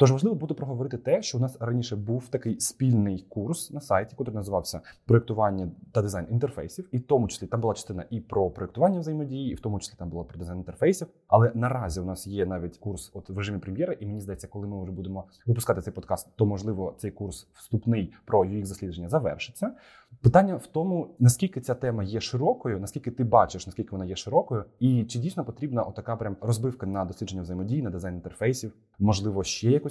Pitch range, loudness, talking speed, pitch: 95-125 Hz, -28 LUFS, 205 wpm, 110 Hz